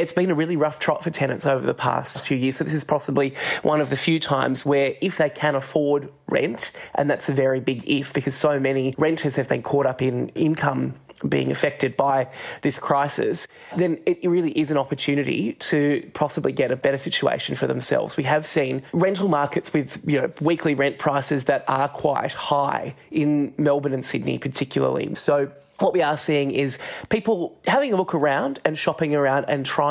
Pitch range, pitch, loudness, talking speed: 135-155 Hz, 145 Hz, -22 LUFS, 200 wpm